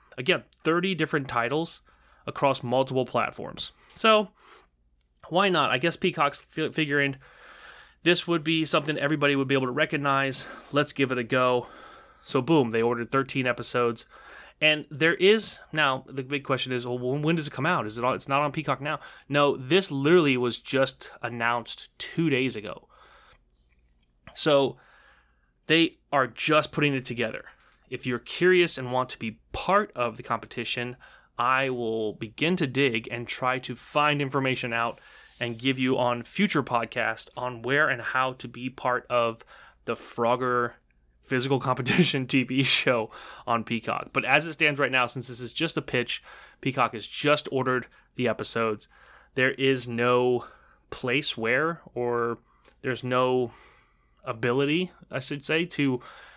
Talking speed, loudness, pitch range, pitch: 160 wpm, -26 LUFS, 120-150 Hz, 130 Hz